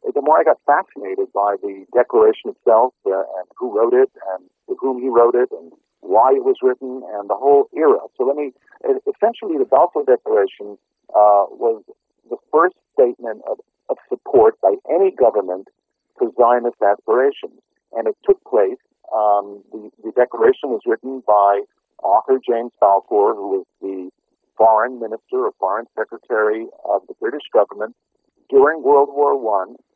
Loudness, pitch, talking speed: -17 LUFS, 390 Hz, 160 wpm